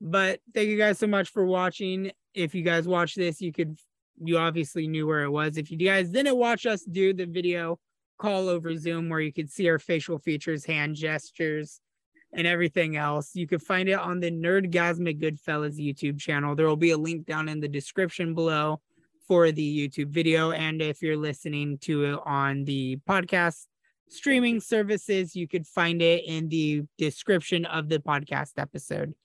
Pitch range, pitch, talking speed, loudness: 155-185 Hz, 165 Hz, 190 wpm, -27 LUFS